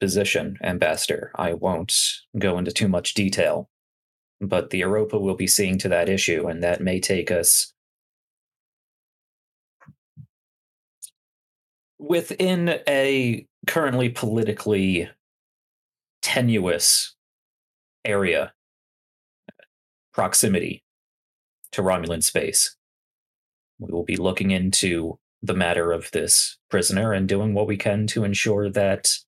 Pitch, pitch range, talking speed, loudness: 100 Hz, 95-110 Hz, 105 wpm, -22 LUFS